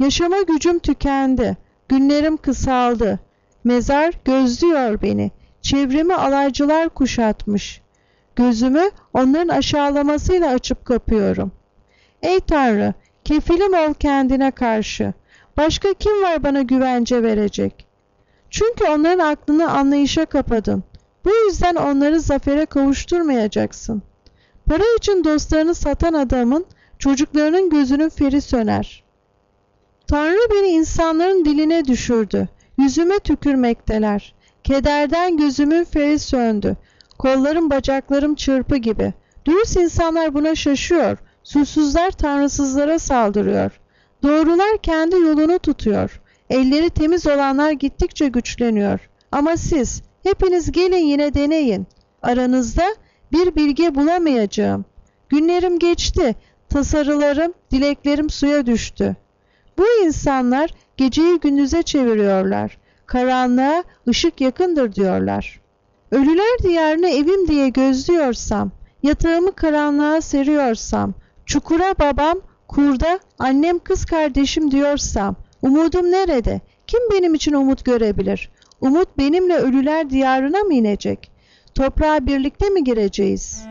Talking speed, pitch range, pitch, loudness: 95 wpm, 245-325 Hz, 285 Hz, -17 LUFS